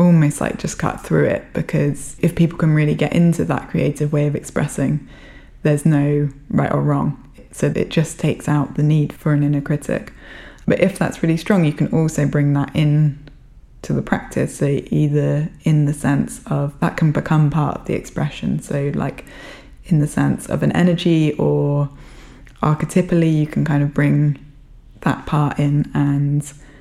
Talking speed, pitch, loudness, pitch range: 180 wpm, 150 Hz, -18 LUFS, 145-155 Hz